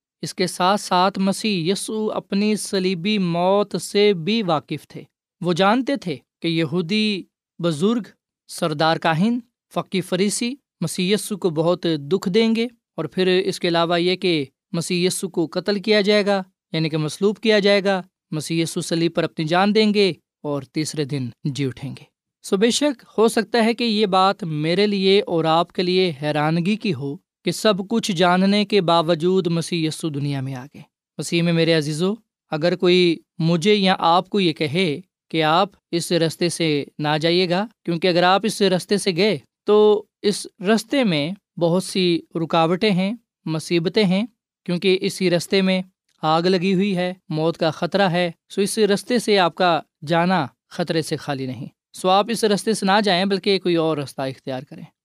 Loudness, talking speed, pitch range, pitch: -20 LUFS, 180 wpm, 165-205 Hz, 185 Hz